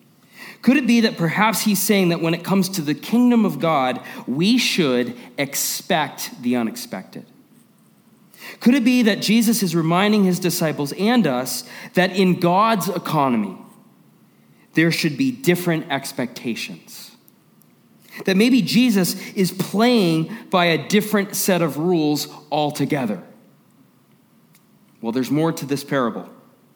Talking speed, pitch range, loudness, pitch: 130 wpm, 165-220 Hz, -19 LUFS, 190 Hz